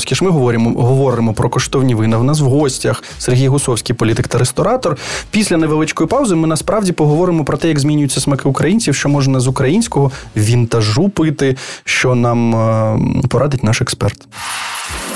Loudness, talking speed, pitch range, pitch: -14 LUFS, 155 wpm, 120-155 Hz, 135 Hz